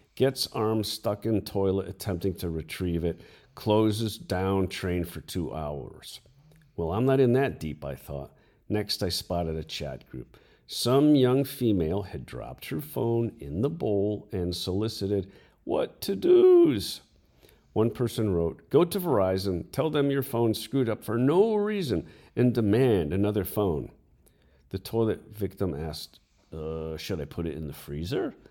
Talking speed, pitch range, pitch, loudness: 160 wpm, 90-125 Hz, 105 Hz, -27 LUFS